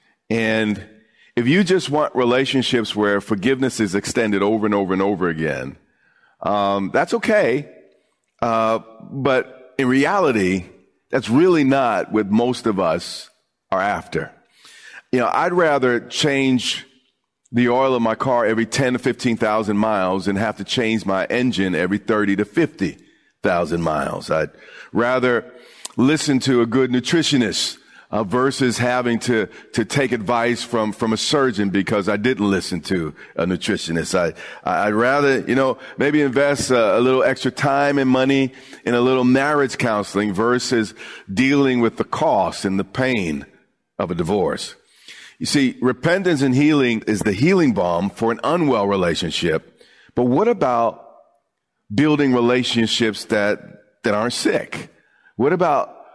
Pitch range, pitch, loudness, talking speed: 105-130 Hz, 120 Hz, -19 LUFS, 150 wpm